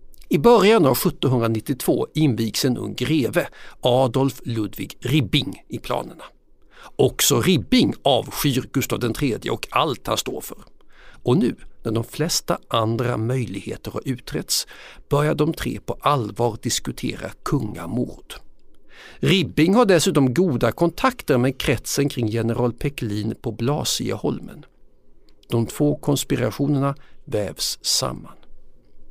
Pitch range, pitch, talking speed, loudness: 115-145 Hz, 125 Hz, 115 wpm, -21 LUFS